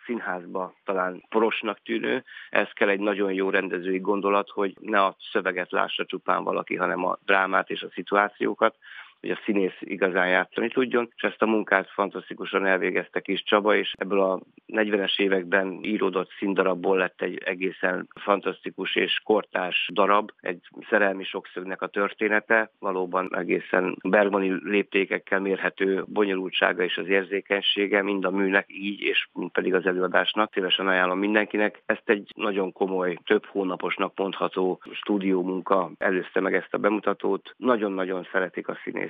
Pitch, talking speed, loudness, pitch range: 95 Hz, 145 wpm, -25 LUFS, 95-100 Hz